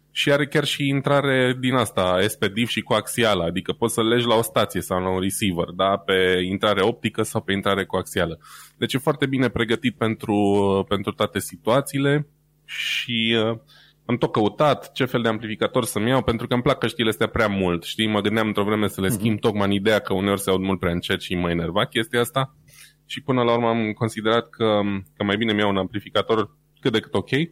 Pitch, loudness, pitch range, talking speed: 110 Hz, -22 LUFS, 100-125 Hz, 215 wpm